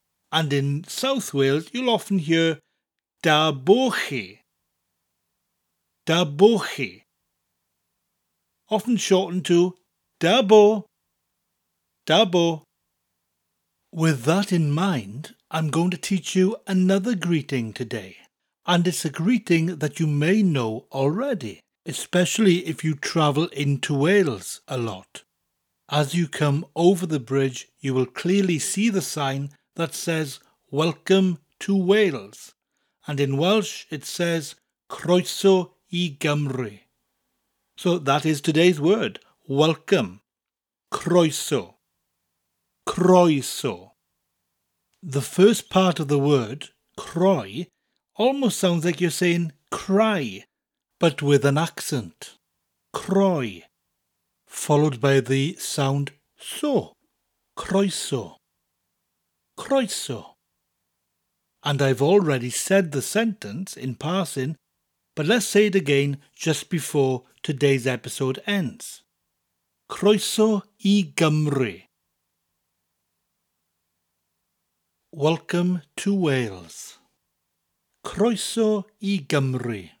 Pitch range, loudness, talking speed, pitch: 125-185 Hz, -22 LUFS, 95 wpm, 155 Hz